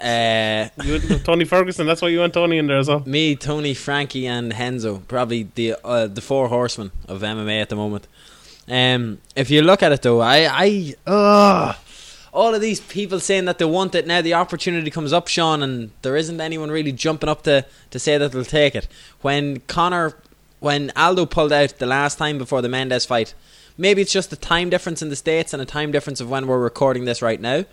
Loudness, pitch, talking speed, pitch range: -19 LUFS, 145 Hz, 215 wpm, 125-170 Hz